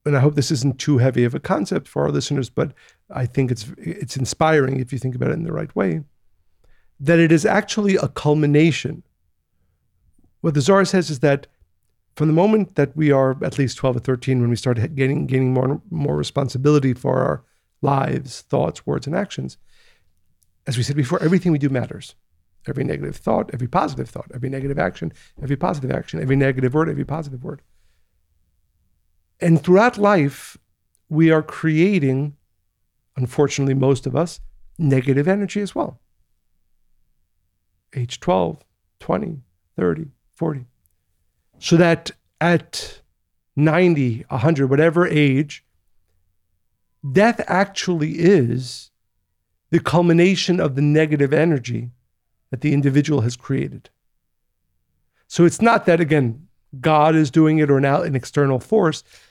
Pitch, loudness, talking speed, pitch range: 135 Hz, -19 LUFS, 150 wpm, 100-160 Hz